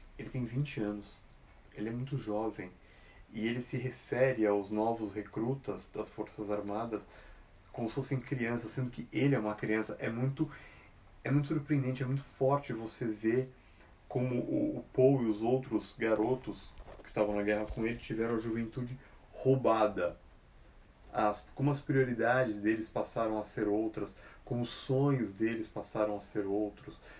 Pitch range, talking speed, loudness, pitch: 105-130 Hz, 160 wpm, -34 LUFS, 110 Hz